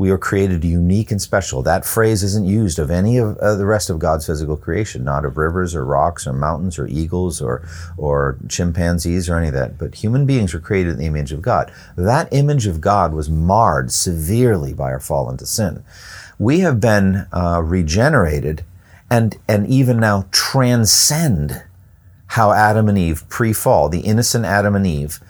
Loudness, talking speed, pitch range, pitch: -17 LUFS, 180 wpm, 80-105 Hz, 90 Hz